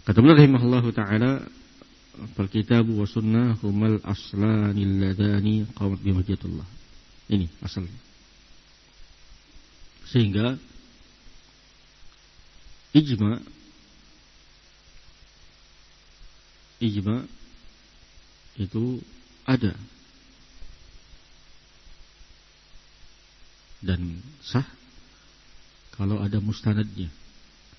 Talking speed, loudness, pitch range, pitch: 55 wpm, -24 LUFS, 85-115 Hz, 105 Hz